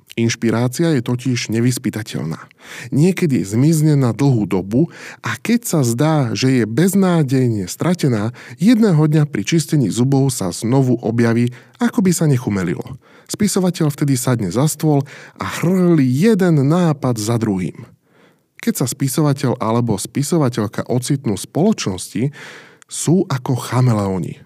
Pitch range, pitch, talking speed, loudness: 120-160 Hz, 135 Hz, 125 wpm, -17 LUFS